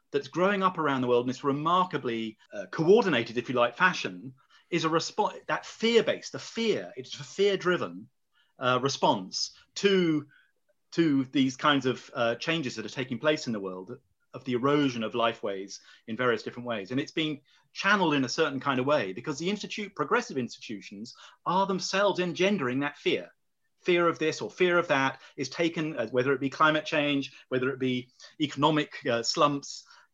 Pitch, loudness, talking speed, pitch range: 145 Hz, -28 LUFS, 180 wpm, 125-175 Hz